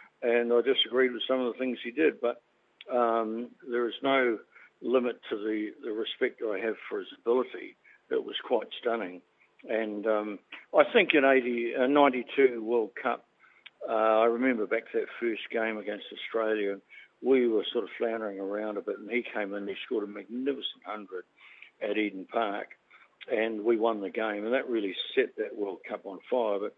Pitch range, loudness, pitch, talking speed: 110-145 Hz, -29 LUFS, 120 Hz, 190 wpm